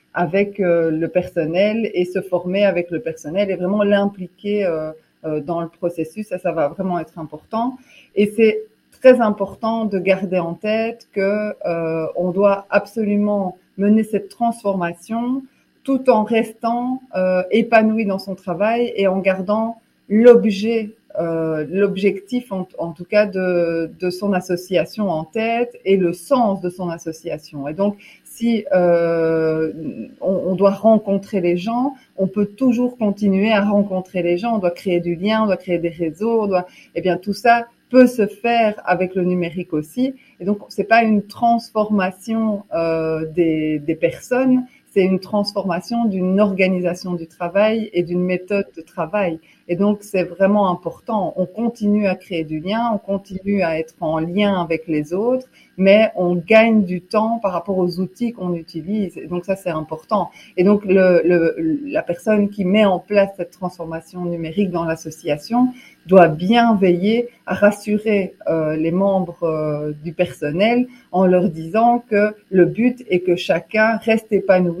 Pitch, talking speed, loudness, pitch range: 195 Hz, 165 wpm, -19 LUFS, 175-215 Hz